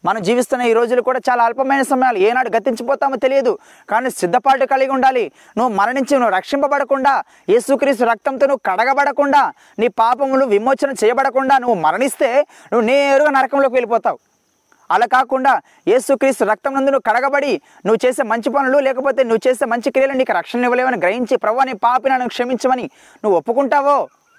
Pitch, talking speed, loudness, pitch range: 265 Hz, 140 wpm, -16 LUFS, 240-275 Hz